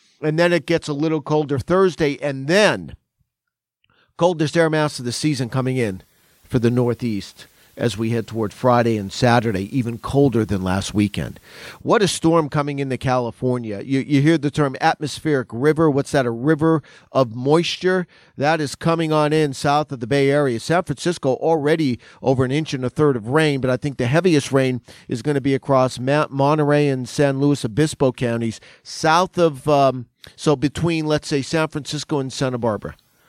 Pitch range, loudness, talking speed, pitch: 125-155 Hz, -20 LUFS, 185 wpm, 140 Hz